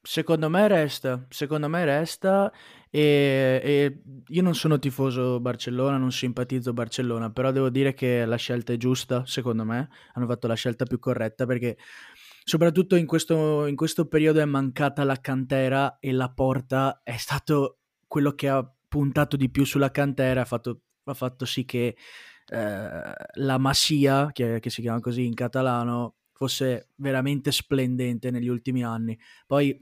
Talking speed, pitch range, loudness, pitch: 160 wpm, 125-145 Hz, -25 LUFS, 130 Hz